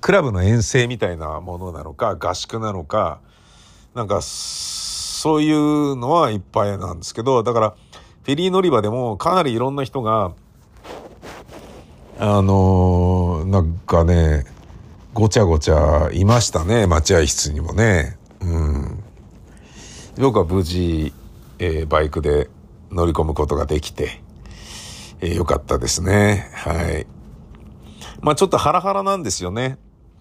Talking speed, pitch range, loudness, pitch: 255 characters per minute, 80-120 Hz, -19 LUFS, 95 Hz